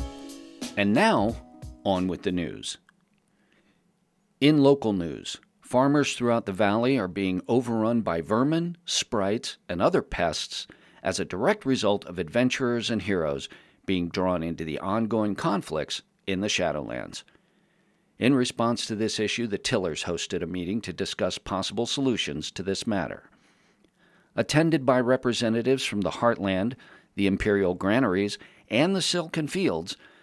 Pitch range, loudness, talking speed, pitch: 95-130 Hz, -26 LUFS, 135 wpm, 110 Hz